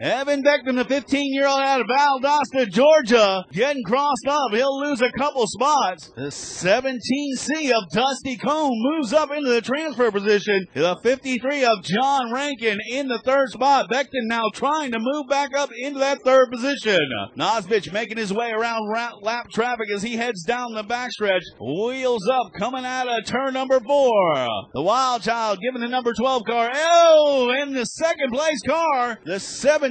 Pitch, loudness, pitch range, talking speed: 255 Hz, -21 LUFS, 230-280 Hz, 170 wpm